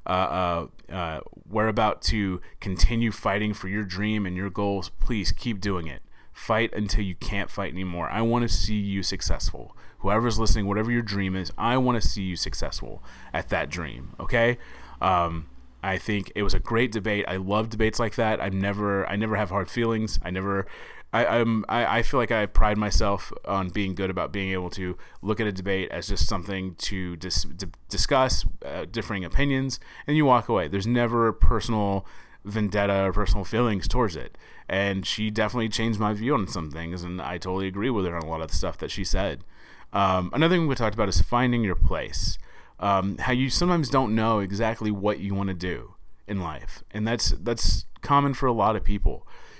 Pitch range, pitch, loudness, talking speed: 95-115 Hz, 100 Hz, -26 LUFS, 205 wpm